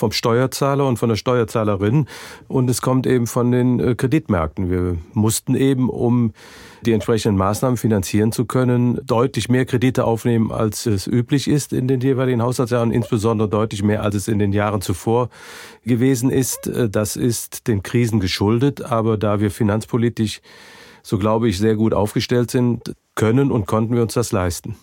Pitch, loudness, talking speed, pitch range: 115 Hz, -19 LUFS, 165 wpm, 110-125 Hz